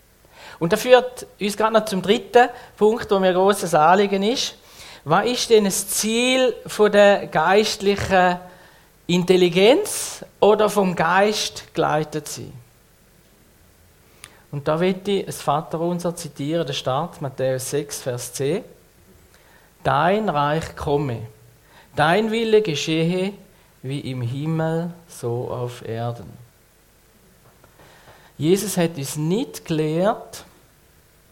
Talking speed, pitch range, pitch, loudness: 110 wpm, 145-205 Hz, 175 Hz, -20 LUFS